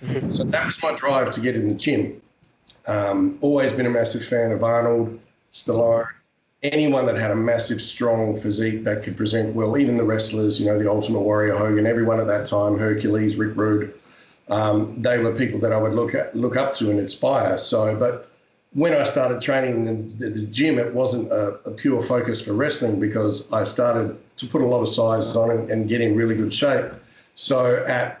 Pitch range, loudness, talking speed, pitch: 105-120 Hz, -21 LUFS, 205 wpm, 115 Hz